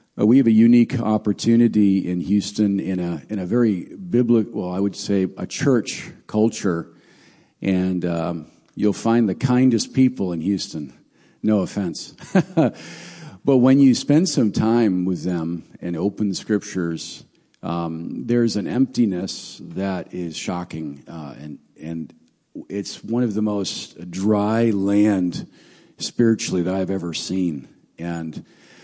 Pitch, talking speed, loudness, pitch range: 100 Hz, 145 wpm, -21 LUFS, 90-115 Hz